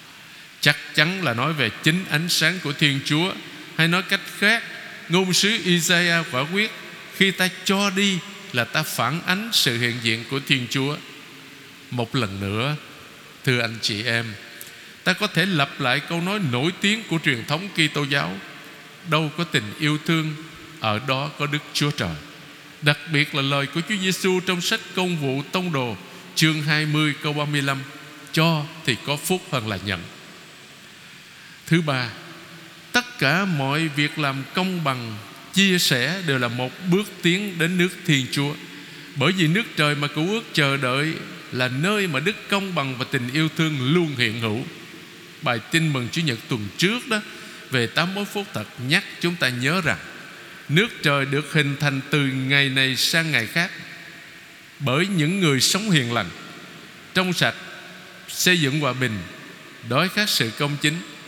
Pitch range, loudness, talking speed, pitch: 135-175 Hz, -22 LUFS, 175 wpm, 150 Hz